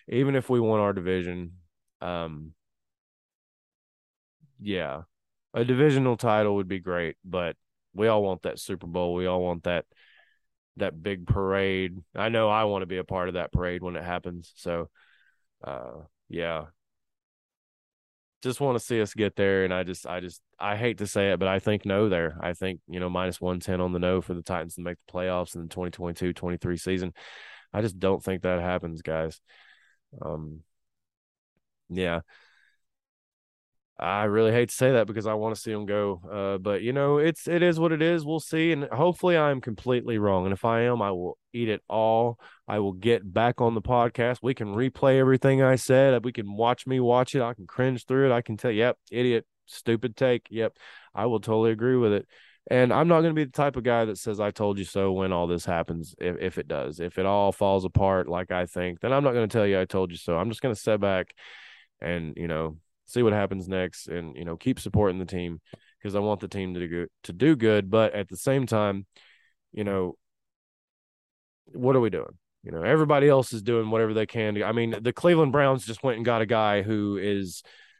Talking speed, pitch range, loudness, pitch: 215 wpm, 90-120 Hz, -26 LUFS, 100 Hz